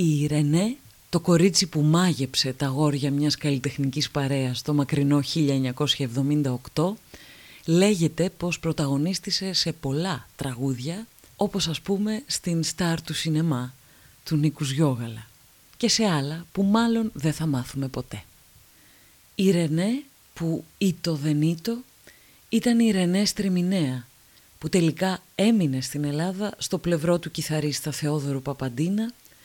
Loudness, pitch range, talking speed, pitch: -25 LUFS, 140-185 Hz, 120 wpm, 155 Hz